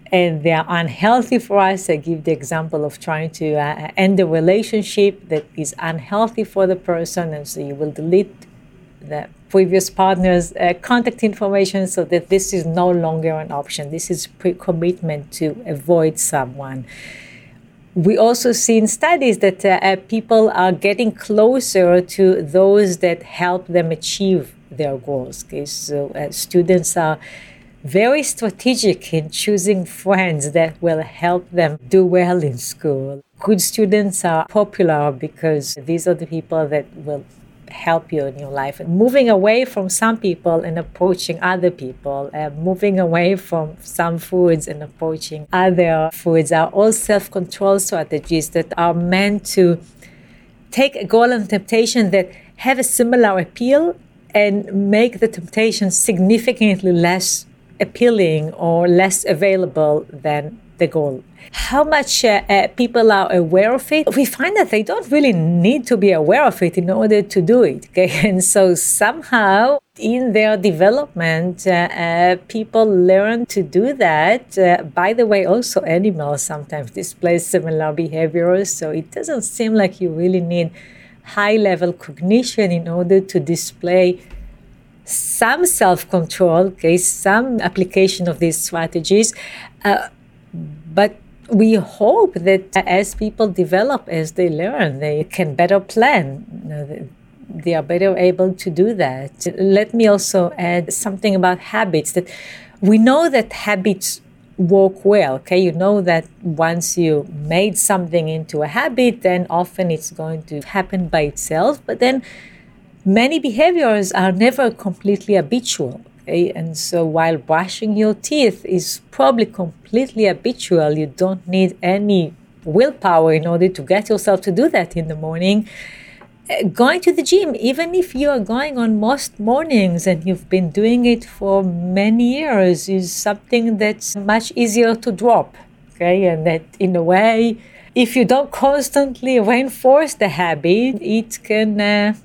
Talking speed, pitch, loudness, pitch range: 150 wpm, 185 Hz, -16 LUFS, 165-215 Hz